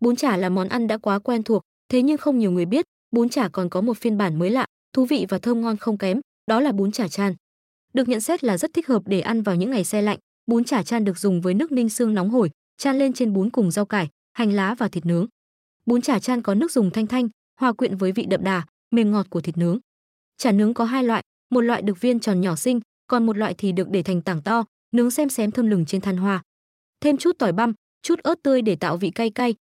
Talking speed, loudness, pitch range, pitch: 270 wpm, -22 LUFS, 195-245 Hz, 225 Hz